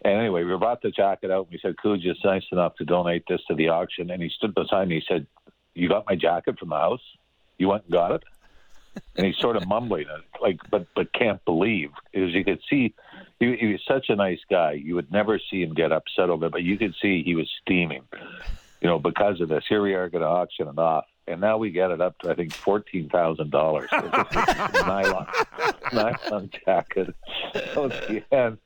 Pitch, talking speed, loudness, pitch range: 95 Hz, 220 wpm, -24 LUFS, 85-100 Hz